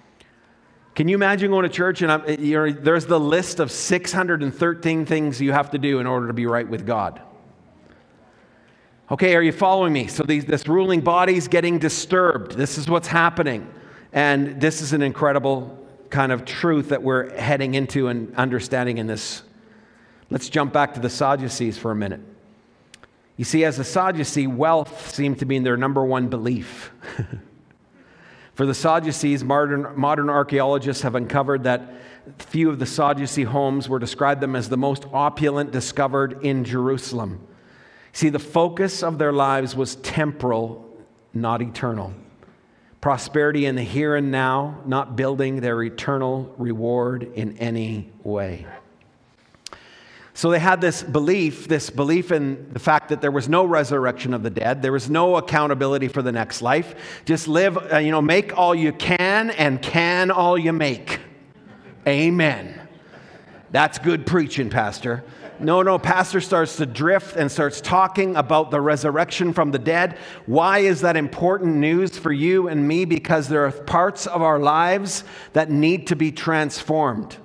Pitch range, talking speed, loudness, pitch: 130-165 Hz, 160 wpm, -21 LUFS, 145 Hz